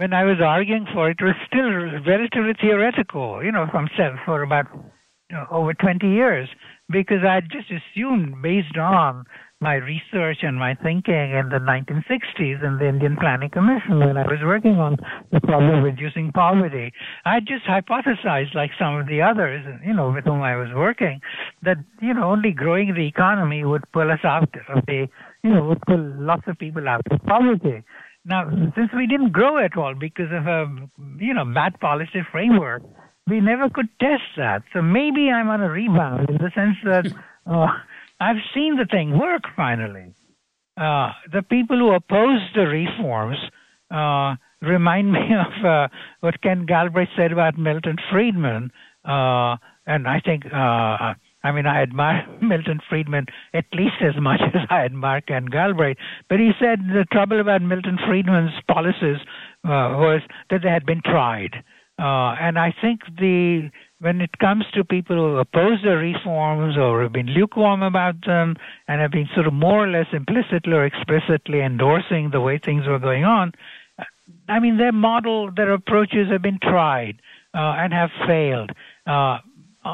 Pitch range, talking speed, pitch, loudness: 145-195 Hz, 175 wpm, 170 Hz, -20 LUFS